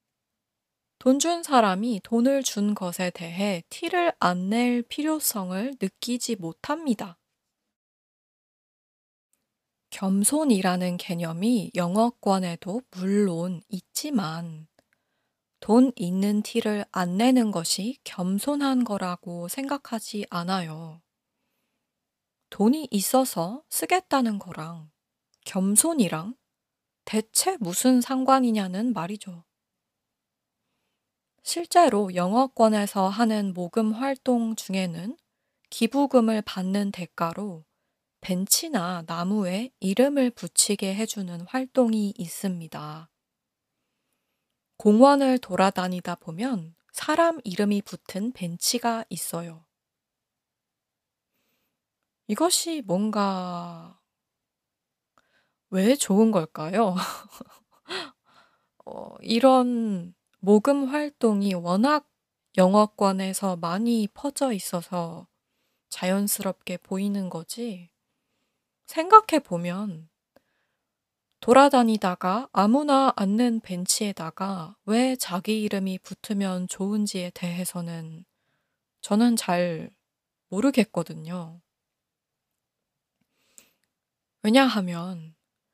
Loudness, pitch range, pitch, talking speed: -24 LUFS, 180-245 Hz, 205 Hz, 180 characters per minute